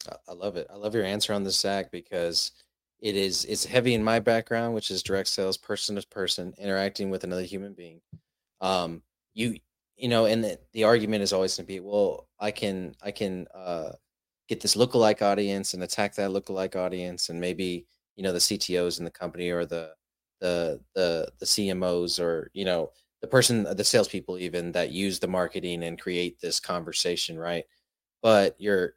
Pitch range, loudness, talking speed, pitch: 90-105 Hz, -27 LUFS, 190 wpm, 95 Hz